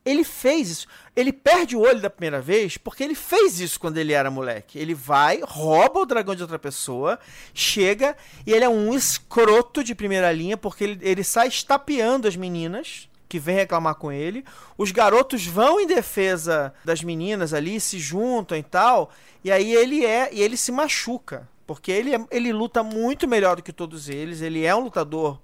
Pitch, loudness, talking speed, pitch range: 205 Hz, -21 LUFS, 190 wpm, 165-245 Hz